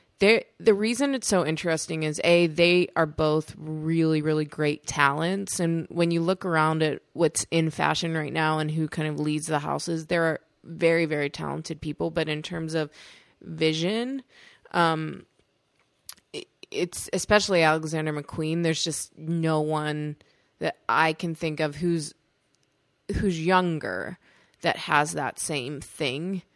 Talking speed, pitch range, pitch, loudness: 150 wpm, 155-170 Hz, 160 Hz, -26 LUFS